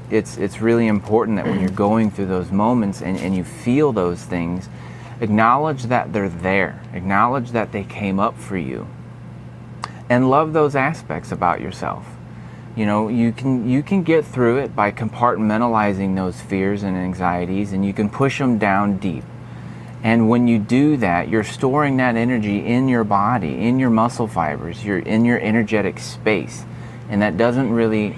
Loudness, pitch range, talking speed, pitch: -19 LUFS, 95-120 Hz, 175 wpm, 110 Hz